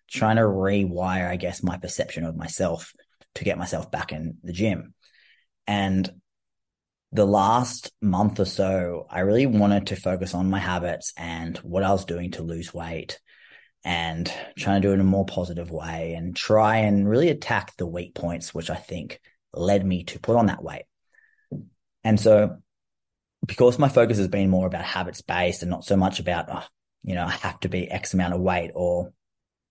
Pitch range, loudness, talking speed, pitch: 90-100 Hz, -24 LUFS, 190 wpm, 95 Hz